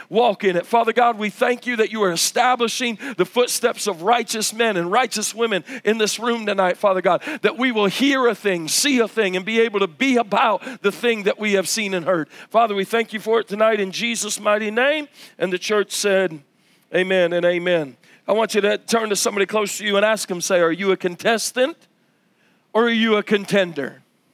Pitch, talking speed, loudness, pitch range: 215 Hz, 220 wpm, -19 LUFS, 195-235 Hz